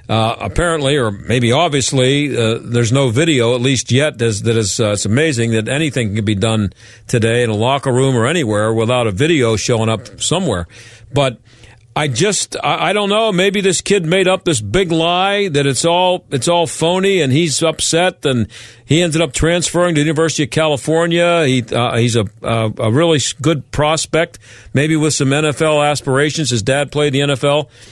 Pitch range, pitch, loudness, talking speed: 115-160 Hz, 140 Hz, -15 LUFS, 185 wpm